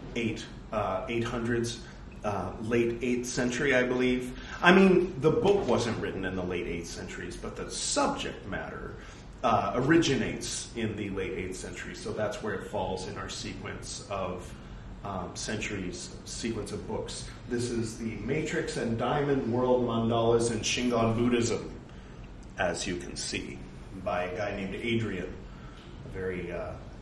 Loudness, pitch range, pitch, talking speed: -30 LUFS, 95-125 Hz, 115 Hz, 155 wpm